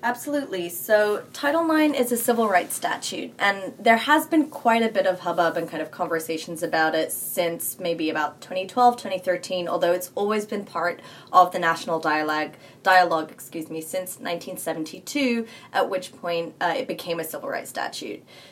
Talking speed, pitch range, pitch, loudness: 170 wpm, 165-230 Hz, 185 Hz, -24 LUFS